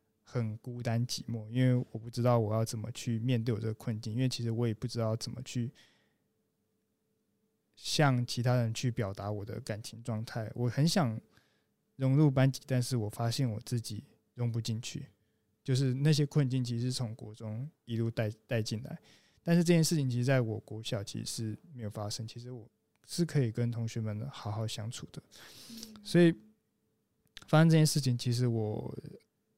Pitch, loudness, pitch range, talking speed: 120 Hz, -32 LUFS, 110-130 Hz, 260 characters per minute